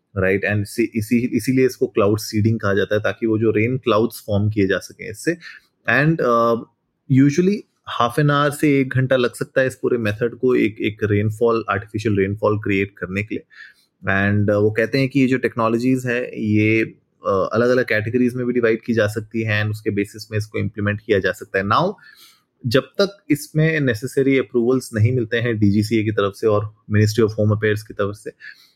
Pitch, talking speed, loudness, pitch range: 115 Hz, 195 wpm, -19 LUFS, 105-130 Hz